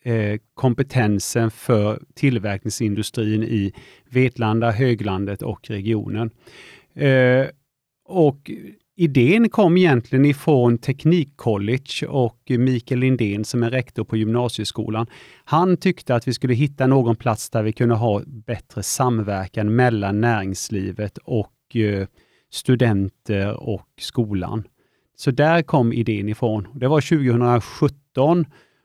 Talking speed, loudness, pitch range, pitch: 105 wpm, -20 LUFS, 110-135 Hz, 120 Hz